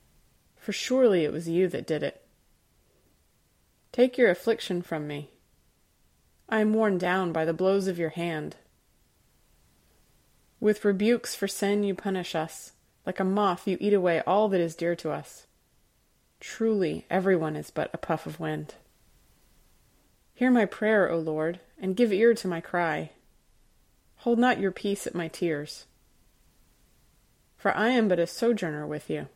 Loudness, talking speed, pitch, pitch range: -27 LUFS, 155 wpm, 180 Hz, 155-205 Hz